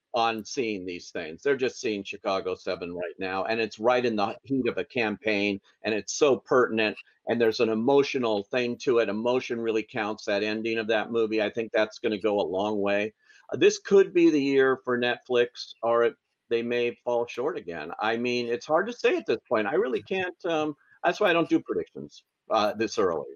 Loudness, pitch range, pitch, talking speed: -27 LUFS, 110-160 Hz, 120 Hz, 220 wpm